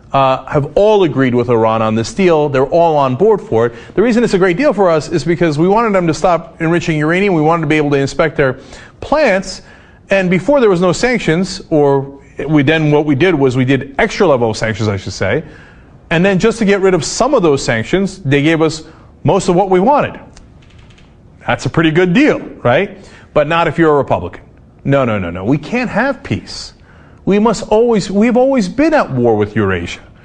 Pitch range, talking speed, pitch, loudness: 135-190 Hz, 220 wpm, 160 Hz, -13 LUFS